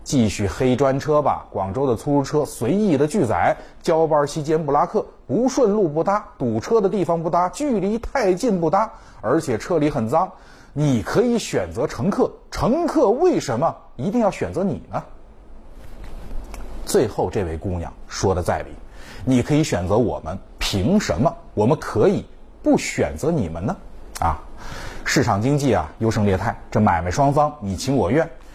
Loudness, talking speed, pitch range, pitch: -21 LUFS, 245 characters per minute, 115-175 Hz, 150 Hz